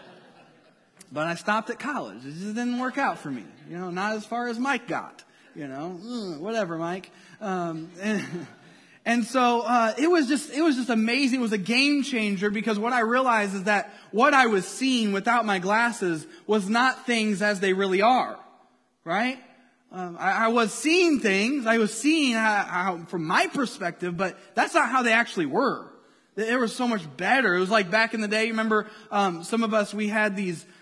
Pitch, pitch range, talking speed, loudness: 220 Hz, 195-245 Hz, 200 wpm, -24 LUFS